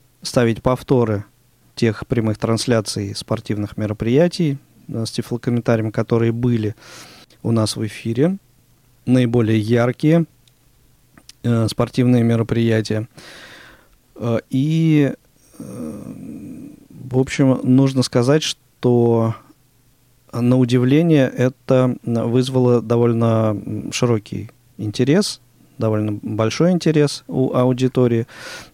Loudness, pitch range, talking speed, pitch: -18 LUFS, 115-130 Hz, 85 wpm, 125 Hz